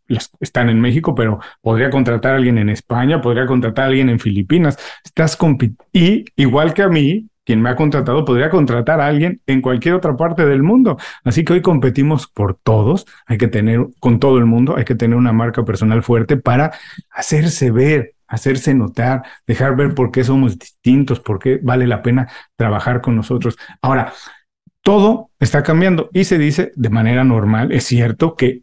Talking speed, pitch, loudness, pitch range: 185 wpm, 130 Hz, -15 LUFS, 120-150 Hz